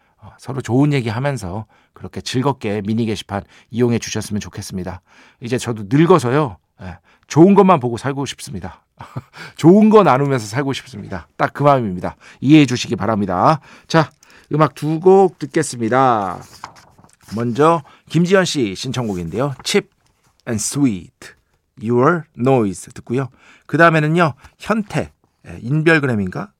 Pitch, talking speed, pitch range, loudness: 130 Hz, 320 characters per minute, 110-155 Hz, -16 LUFS